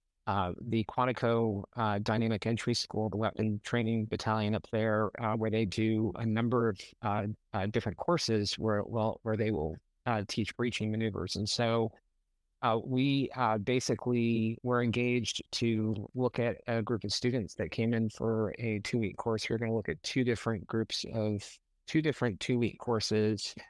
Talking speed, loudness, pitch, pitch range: 175 wpm, -32 LUFS, 110 Hz, 105-120 Hz